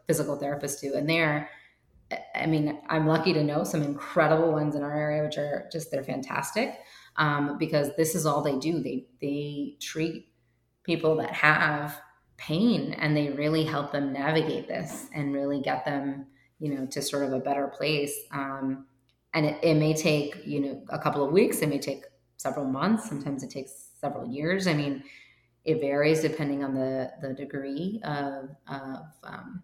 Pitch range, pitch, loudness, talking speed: 140-155 Hz, 145 Hz, -28 LUFS, 175 wpm